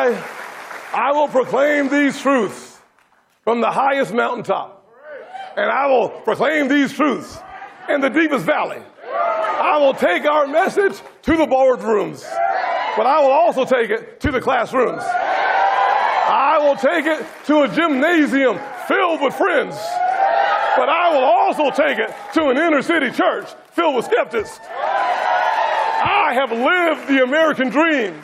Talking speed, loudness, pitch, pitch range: 140 wpm, -17 LUFS, 300 Hz, 275-345 Hz